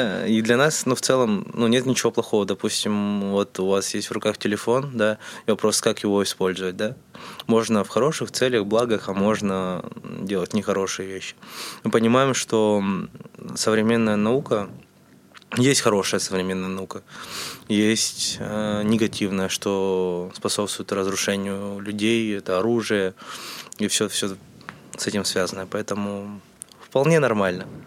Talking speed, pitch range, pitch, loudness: 130 wpm, 100-115 Hz, 105 Hz, -23 LUFS